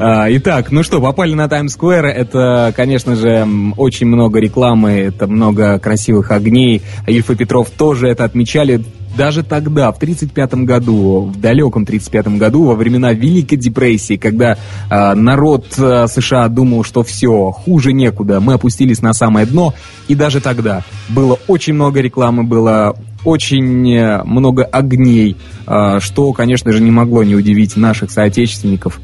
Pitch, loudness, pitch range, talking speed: 120 Hz, -11 LUFS, 105-130 Hz, 140 wpm